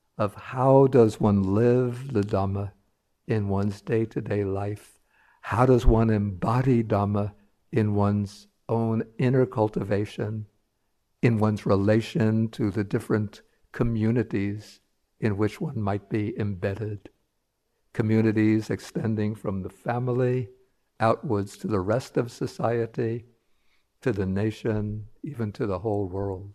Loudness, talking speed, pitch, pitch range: -26 LUFS, 120 wpm, 110 Hz, 100-115 Hz